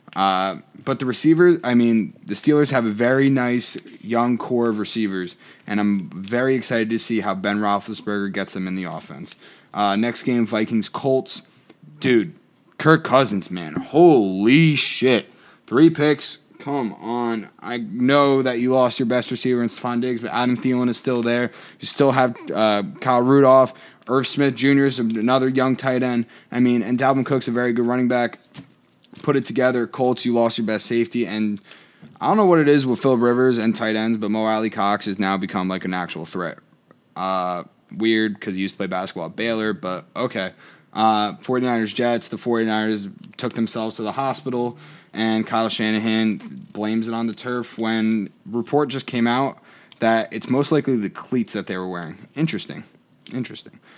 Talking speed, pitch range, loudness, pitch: 185 wpm, 110-130 Hz, -20 LUFS, 120 Hz